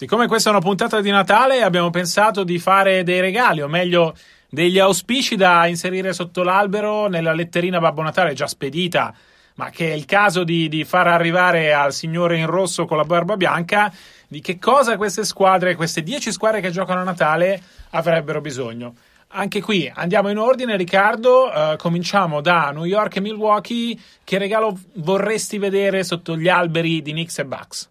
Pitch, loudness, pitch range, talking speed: 185 Hz, -18 LUFS, 170-205 Hz, 175 wpm